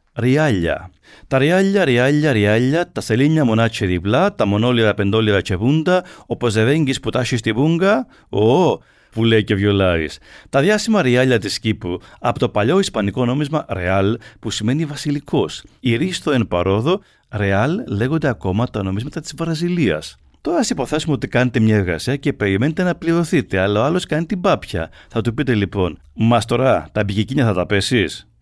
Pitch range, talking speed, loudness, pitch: 105-150 Hz, 165 wpm, -18 LUFS, 120 Hz